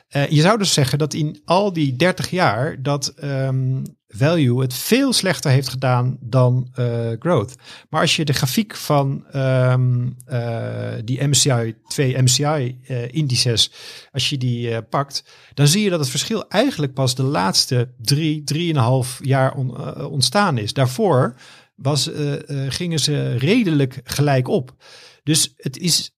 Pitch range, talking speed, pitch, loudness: 125-150 Hz, 160 wpm, 140 Hz, -19 LUFS